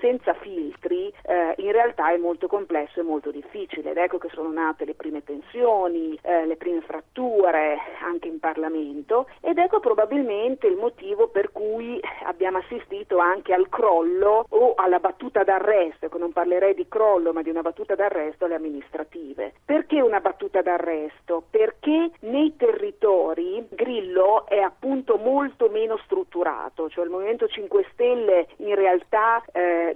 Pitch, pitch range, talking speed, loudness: 200 Hz, 170-280 Hz, 150 wpm, -23 LUFS